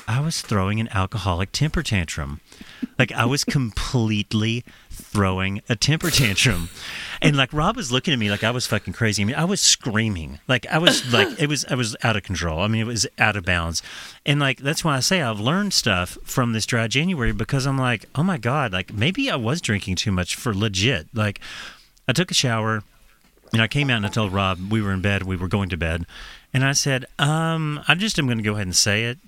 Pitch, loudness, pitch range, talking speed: 115 Hz, -21 LUFS, 100-140 Hz, 235 wpm